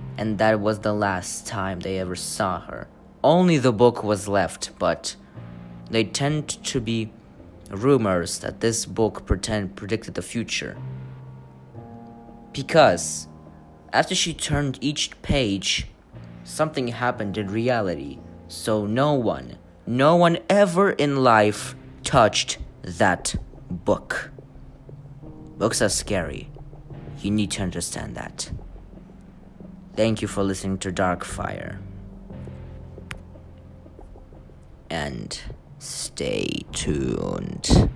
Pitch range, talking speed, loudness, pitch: 90-130 Hz, 105 wpm, -23 LUFS, 105 Hz